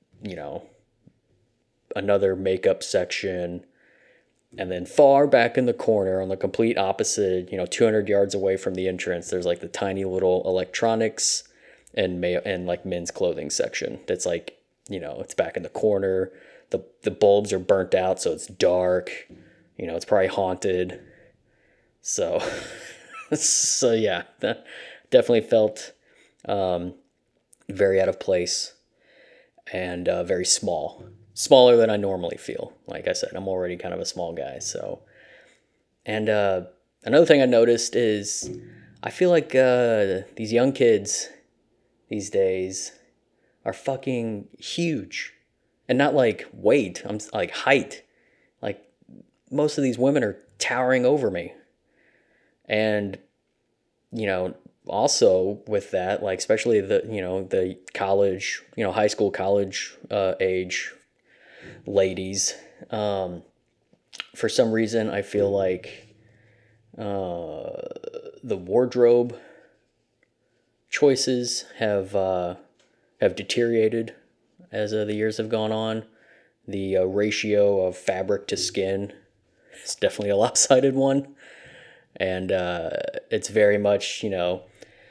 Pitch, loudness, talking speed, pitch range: 105 Hz, -23 LUFS, 130 wpm, 95-125 Hz